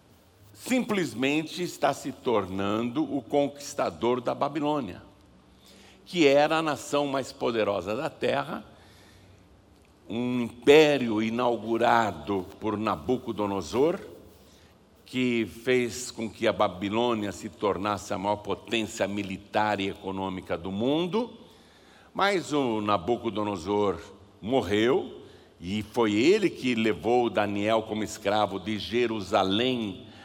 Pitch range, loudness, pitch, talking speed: 100-130 Hz, -27 LUFS, 110 Hz, 100 wpm